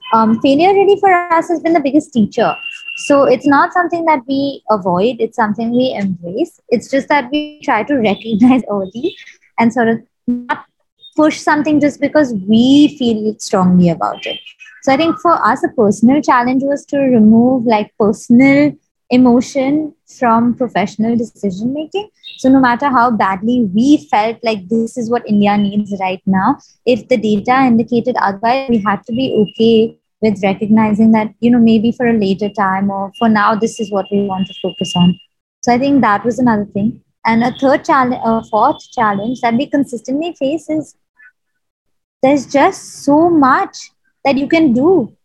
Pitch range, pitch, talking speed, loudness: 215-285 Hz, 245 Hz, 175 wpm, -13 LUFS